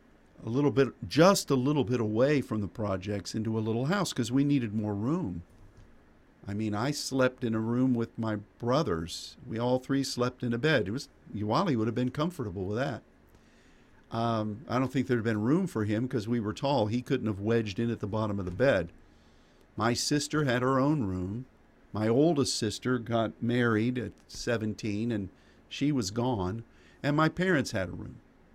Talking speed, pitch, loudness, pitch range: 195 wpm, 115 Hz, -30 LUFS, 105-130 Hz